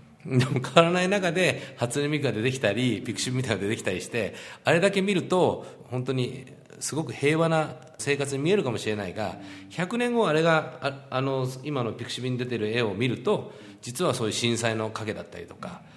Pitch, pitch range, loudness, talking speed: 130 Hz, 115-155 Hz, -26 LUFS, 400 characters per minute